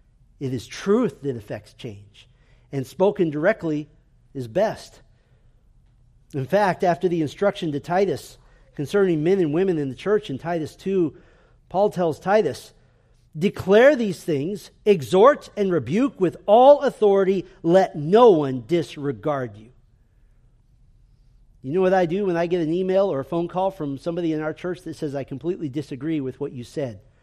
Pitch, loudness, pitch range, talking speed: 155 Hz, -22 LUFS, 130-185 Hz, 160 wpm